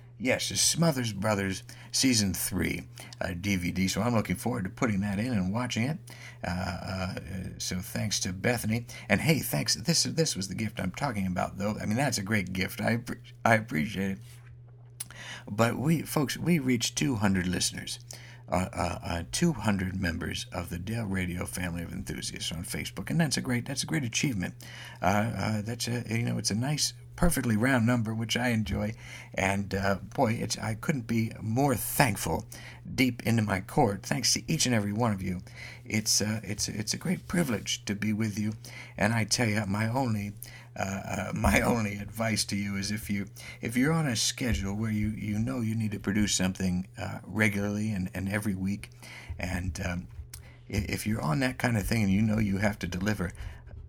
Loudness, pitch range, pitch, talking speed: -29 LUFS, 95-120 Hz, 105 Hz, 195 wpm